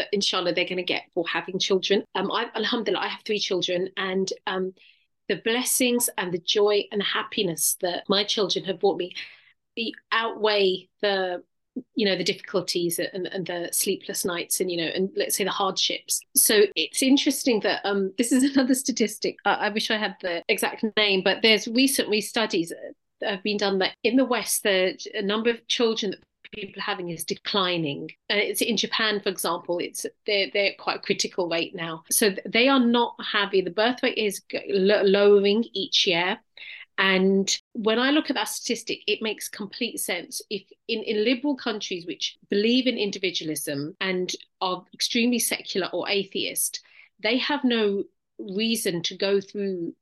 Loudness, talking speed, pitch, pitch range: -24 LUFS, 180 wpm, 205 Hz, 190-230 Hz